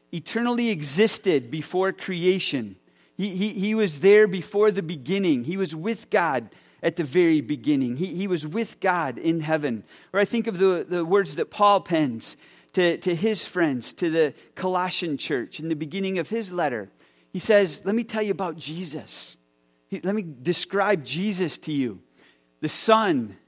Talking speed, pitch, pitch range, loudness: 170 wpm, 185 Hz, 160-210 Hz, -24 LUFS